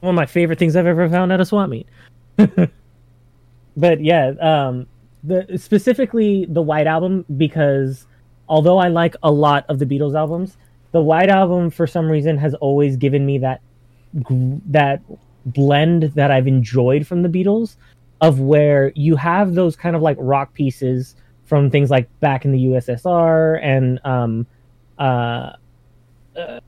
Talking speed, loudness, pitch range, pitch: 155 wpm, -16 LUFS, 125-170 Hz, 145 Hz